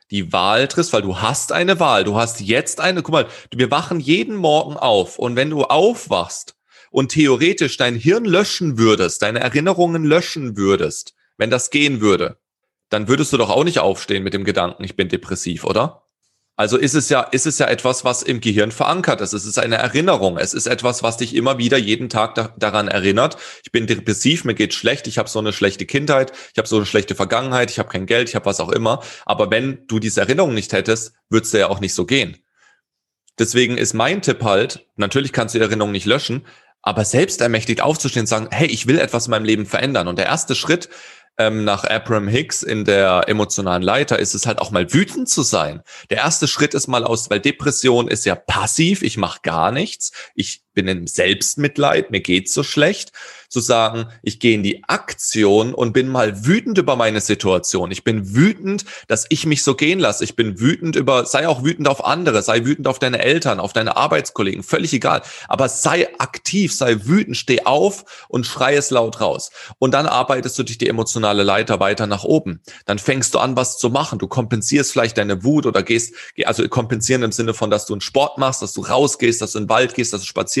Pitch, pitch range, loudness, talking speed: 115 Hz, 105-135 Hz, -17 LUFS, 215 wpm